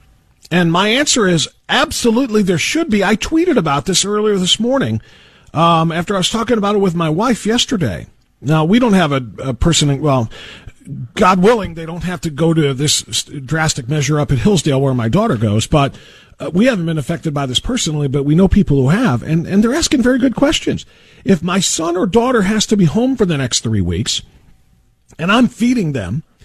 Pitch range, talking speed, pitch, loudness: 140-215 Hz, 210 wpm, 170 Hz, -14 LUFS